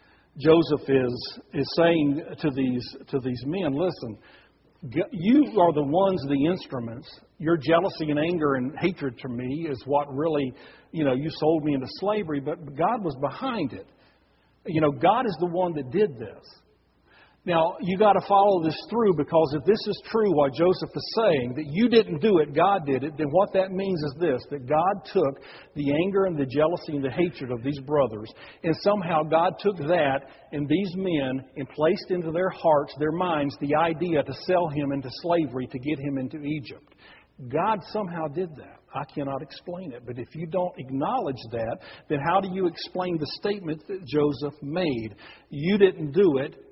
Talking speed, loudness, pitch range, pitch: 190 wpm, -25 LUFS, 140-180 Hz, 155 Hz